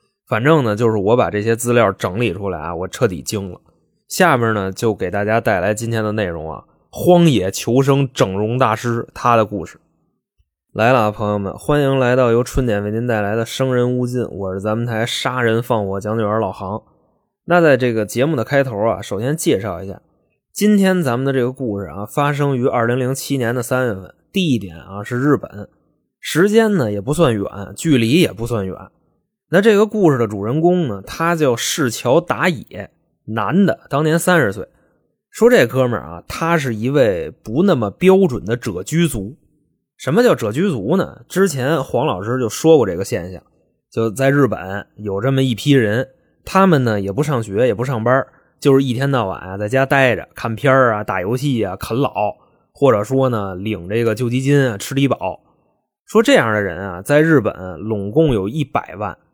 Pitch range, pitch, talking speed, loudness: 105-140 Hz, 120 Hz, 270 characters per minute, -17 LUFS